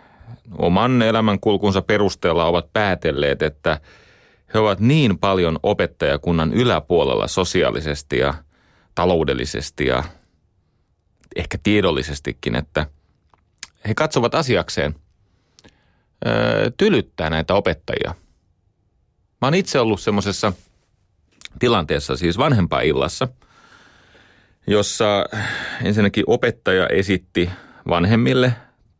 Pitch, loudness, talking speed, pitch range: 95 Hz, -19 LUFS, 85 wpm, 85-110 Hz